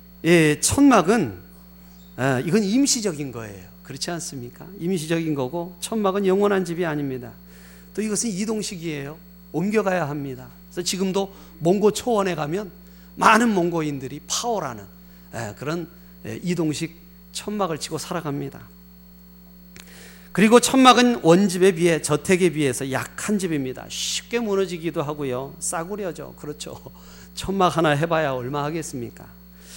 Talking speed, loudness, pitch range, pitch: 305 characters per minute, -22 LUFS, 130-190 Hz, 165 Hz